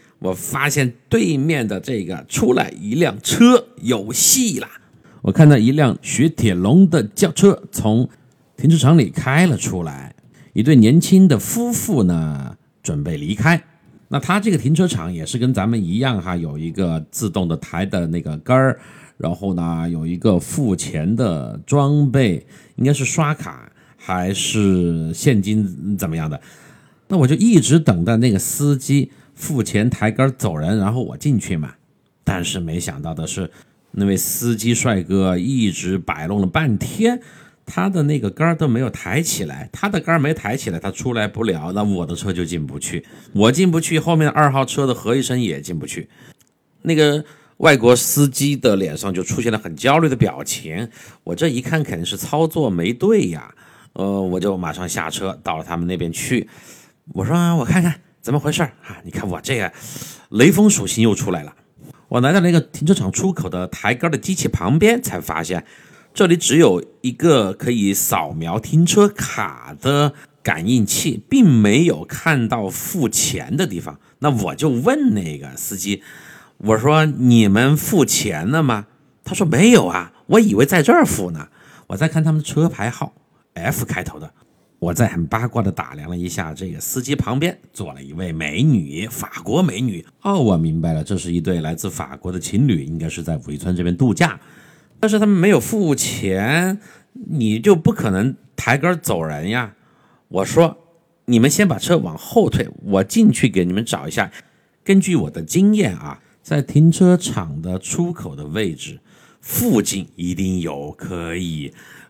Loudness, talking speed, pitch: -18 LUFS, 250 characters per minute, 125 Hz